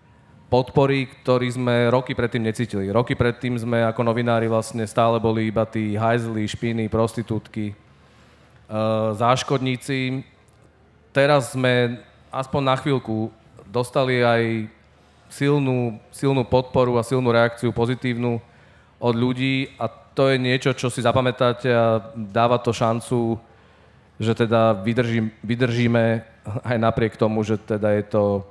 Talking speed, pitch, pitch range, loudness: 125 wpm, 120 Hz, 110-125 Hz, -22 LUFS